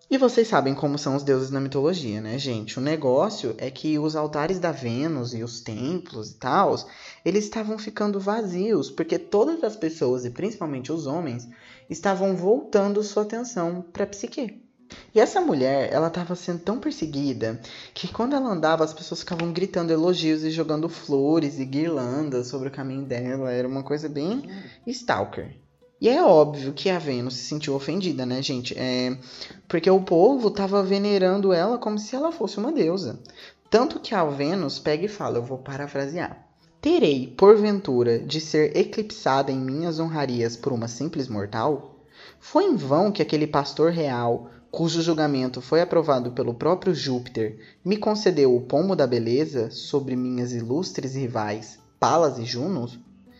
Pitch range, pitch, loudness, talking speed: 130-195 Hz, 155 Hz, -24 LUFS, 165 wpm